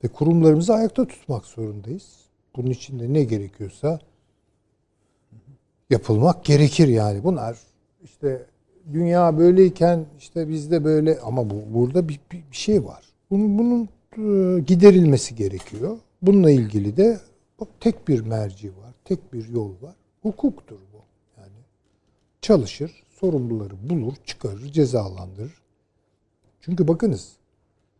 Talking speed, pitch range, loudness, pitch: 110 wpm, 105-175 Hz, -20 LUFS, 135 Hz